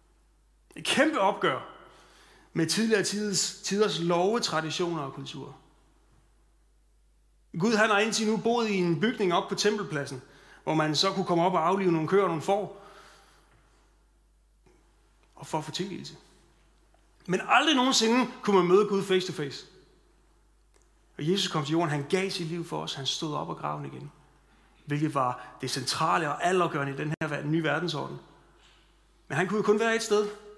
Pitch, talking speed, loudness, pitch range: 175 Hz, 175 wpm, -27 LUFS, 155-205 Hz